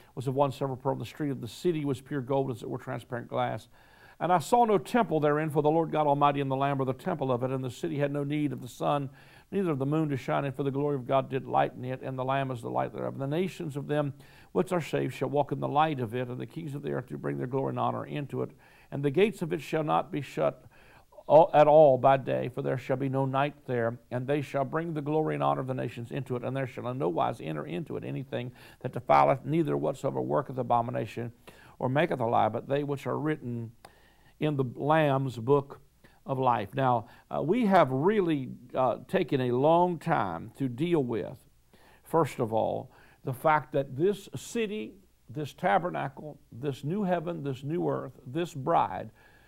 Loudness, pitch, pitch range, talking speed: -29 LUFS, 140 Hz, 125-155 Hz, 235 wpm